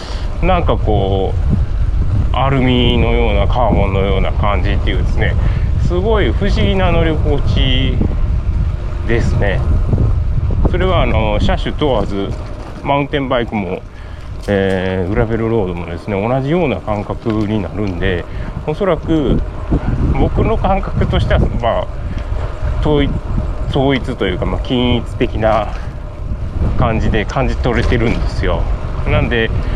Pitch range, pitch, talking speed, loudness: 90-115 Hz, 100 Hz, 265 characters per minute, -16 LUFS